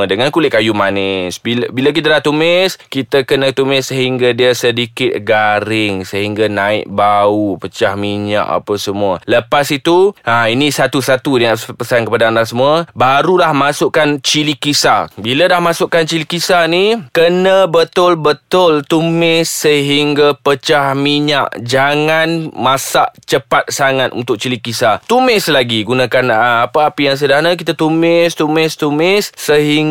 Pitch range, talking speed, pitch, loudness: 120-160 Hz, 140 wpm, 140 Hz, -12 LUFS